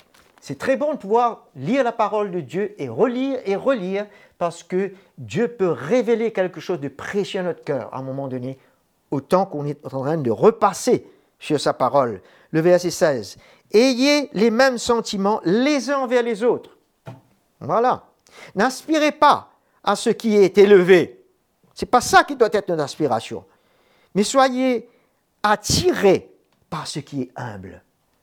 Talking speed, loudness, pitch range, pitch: 165 wpm, -20 LUFS, 170-250 Hz, 205 Hz